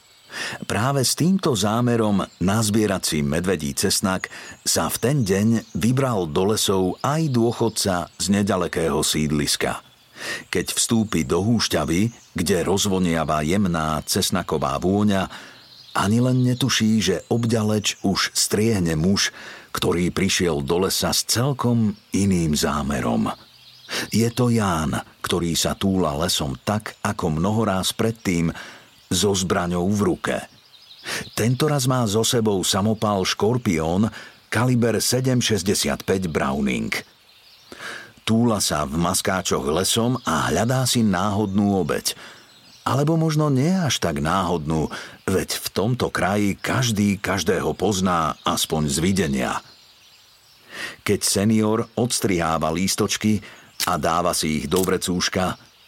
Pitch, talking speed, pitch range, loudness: 105 Hz, 110 wpm, 90-115 Hz, -21 LUFS